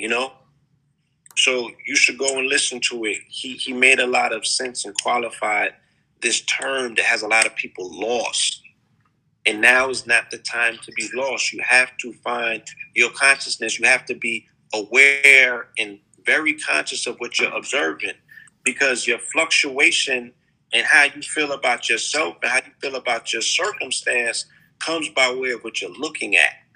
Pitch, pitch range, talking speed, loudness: 130 Hz, 115-140 Hz, 175 wpm, -19 LUFS